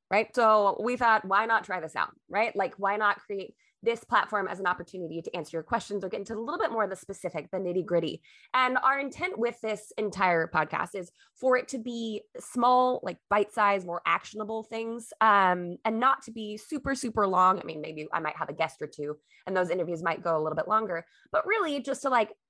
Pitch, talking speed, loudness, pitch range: 210 Hz, 230 wpm, -28 LUFS, 180-240 Hz